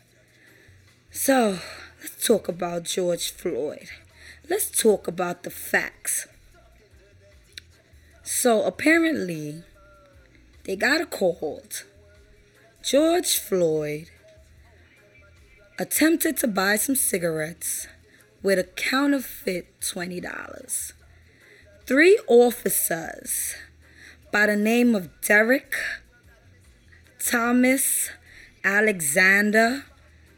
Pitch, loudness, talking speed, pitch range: 205 Hz, -22 LUFS, 75 wpm, 170-260 Hz